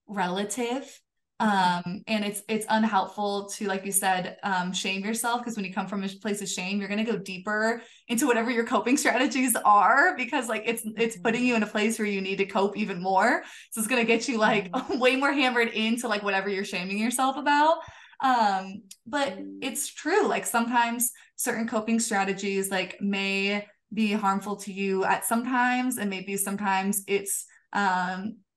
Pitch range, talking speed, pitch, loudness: 195-240 Hz, 185 wpm, 215 Hz, -26 LUFS